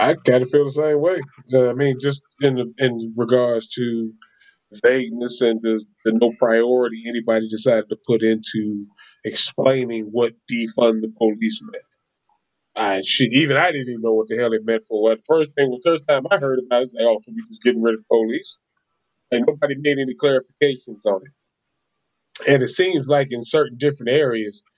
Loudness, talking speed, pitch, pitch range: -19 LUFS, 200 wpm, 125 Hz, 115-145 Hz